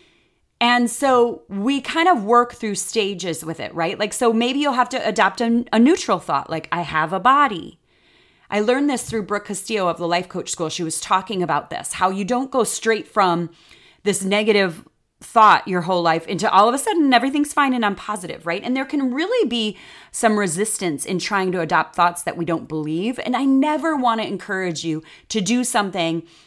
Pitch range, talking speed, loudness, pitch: 175-245 Hz, 210 wpm, -20 LUFS, 210 Hz